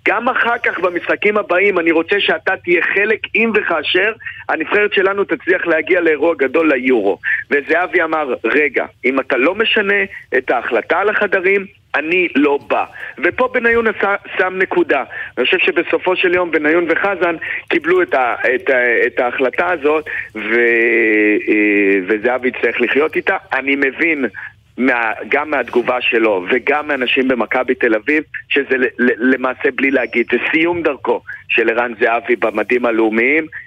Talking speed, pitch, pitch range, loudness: 145 wpm, 165 Hz, 125-200 Hz, -15 LUFS